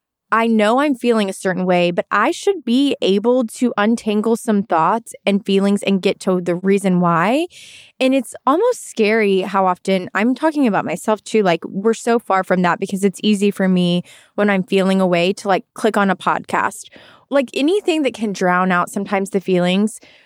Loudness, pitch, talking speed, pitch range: -17 LUFS, 205 Hz, 195 wpm, 190-235 Hz